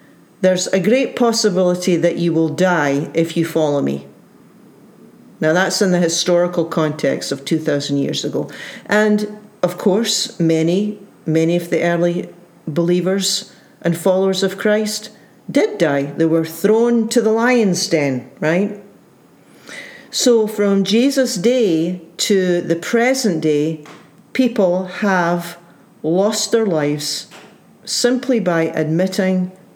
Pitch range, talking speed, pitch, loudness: 165-210 Hz, 125 wpm, 185 Hz, -17 LUFS